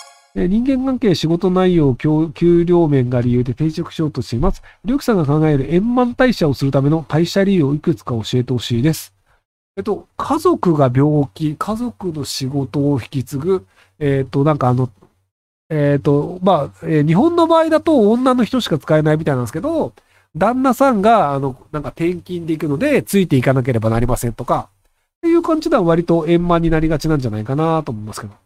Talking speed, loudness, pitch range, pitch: 385 characters per minute, -16 LUFS, 135-185 Hz, 155 Hz